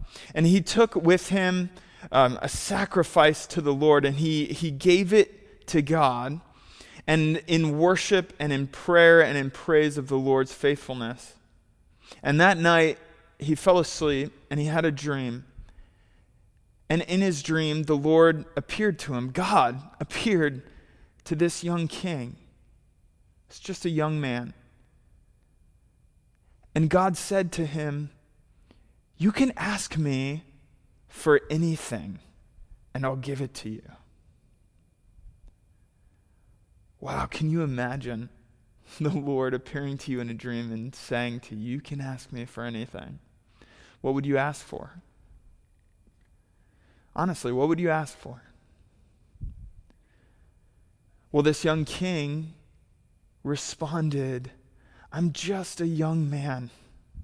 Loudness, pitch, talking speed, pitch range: -25 LUFS, 145 Hz, 130 wpm, 120-165 Hz